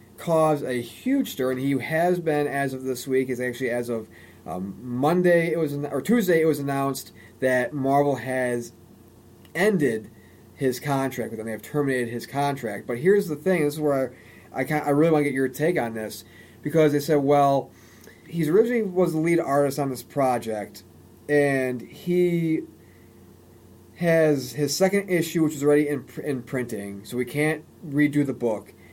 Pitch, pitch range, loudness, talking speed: 135 Hz, 115-150 Hz, -24 LUFS, 185 wpm